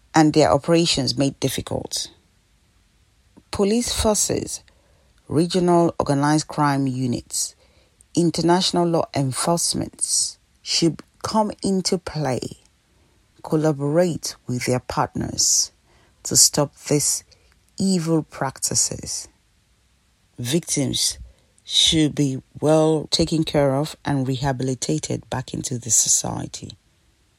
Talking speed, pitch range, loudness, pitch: 90 wpm, 125-165 Hz, -20 LUFS, 145 Hz